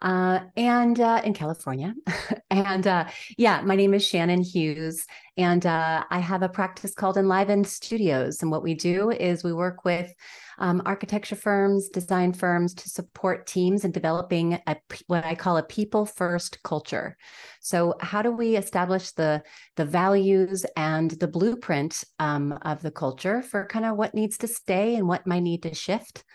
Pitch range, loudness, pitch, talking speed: 170-200 Hz, -25 LUFS, 185 Hz, 175 wpm